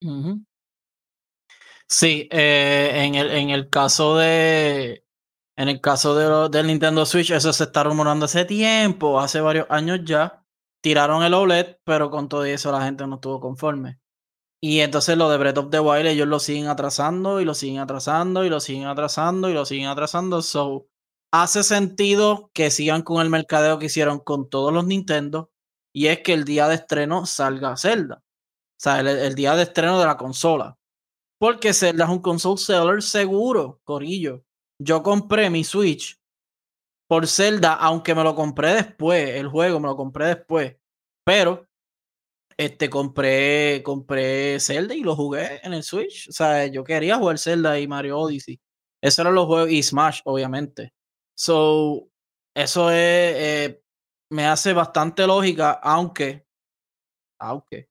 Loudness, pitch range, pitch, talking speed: -20 LUFS, 140-170 Hz, 155 Hz, 165 wpm